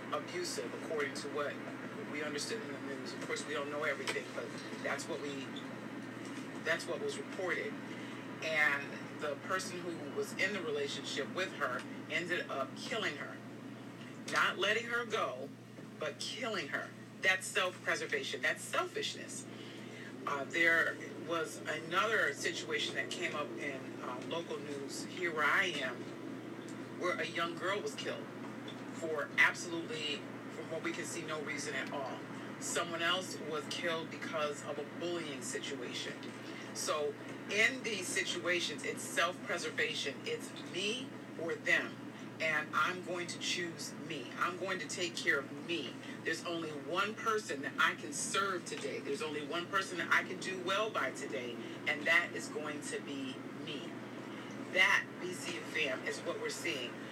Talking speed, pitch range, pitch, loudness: 150 wpm, 150-225 Hz, 170 Hz, -37 LUFS